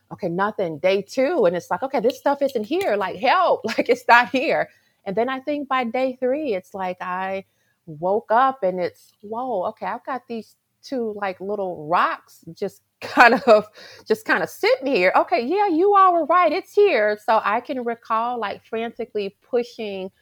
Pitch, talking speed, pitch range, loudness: 230 Hz, 190 wpm, 195-265 Hz, -21 LUFS